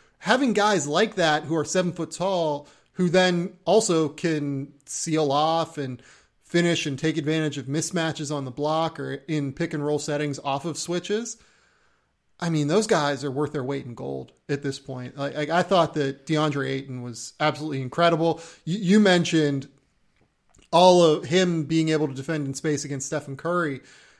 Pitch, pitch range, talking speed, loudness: 155 Hz, 140-170 Hz, 175 wpm, -24 LUFS